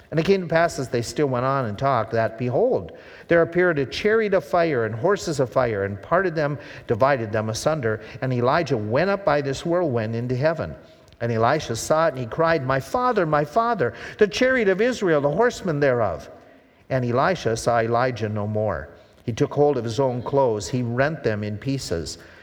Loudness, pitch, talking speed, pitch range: -22 LUFS, 135 Hz, 200 wpm, 115-165 Hz